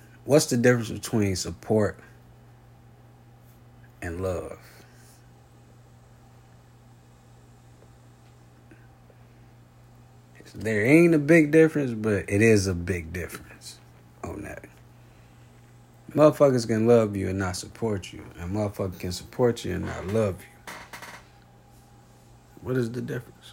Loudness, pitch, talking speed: -24 LUFS, 105 Hz, 105 wpm